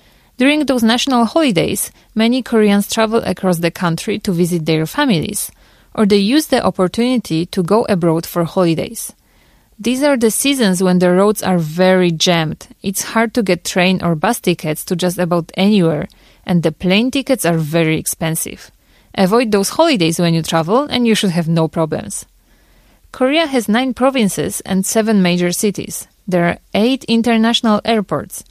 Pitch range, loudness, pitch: 175-230 Hz, -15 LUFS, 195 Hz